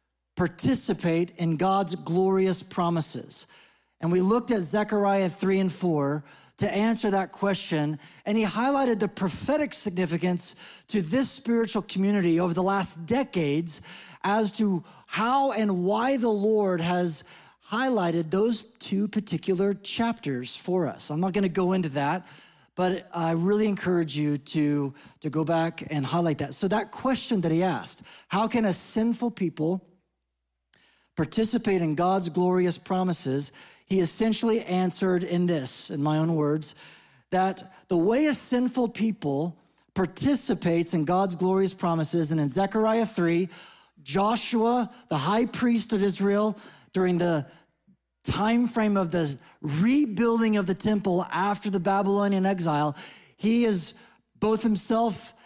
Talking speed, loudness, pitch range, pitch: 140 wpm, -26 LUFS, 170-215 Hz, 190 Hz